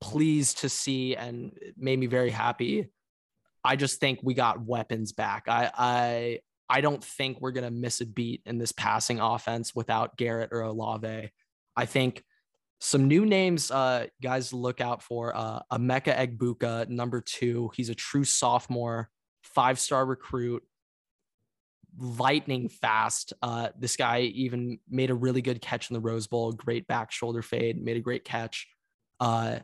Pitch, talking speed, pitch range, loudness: 120 Hz, 160 wpm, 115-130 Hz, -29 LUFS